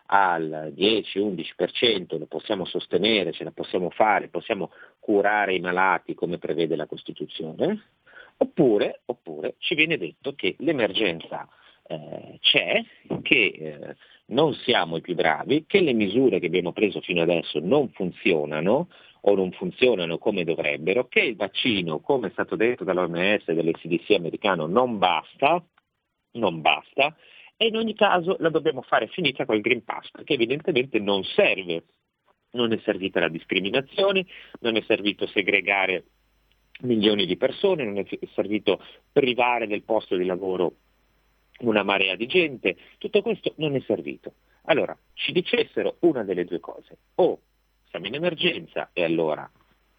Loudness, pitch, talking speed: -24 LUFS, 115 Hz, 145 wpm